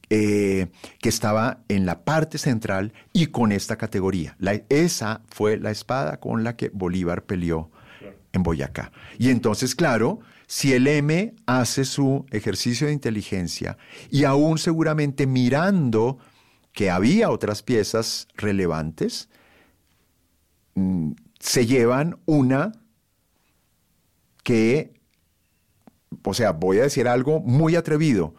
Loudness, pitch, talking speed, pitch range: -22 LUFS, 110 Hz, 120 wpm, 95-135 Hz